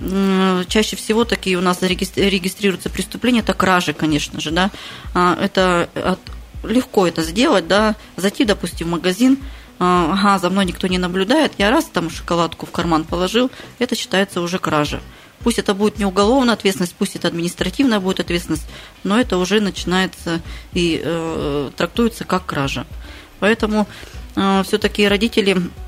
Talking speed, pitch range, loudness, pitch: 145 wpm, 175-210 Hz, -18 LUFS, 190 Hz